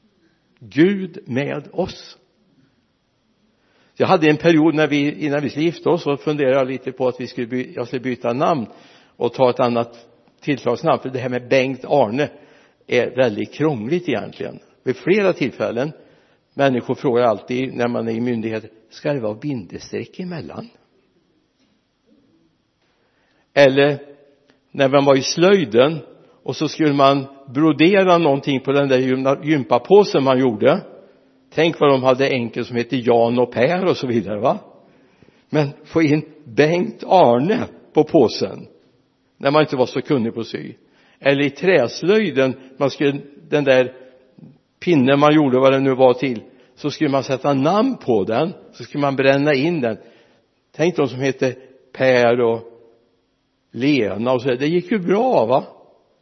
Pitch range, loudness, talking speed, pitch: 125-150 Hz, -18 LUFS, 160 wpm, 135 Hz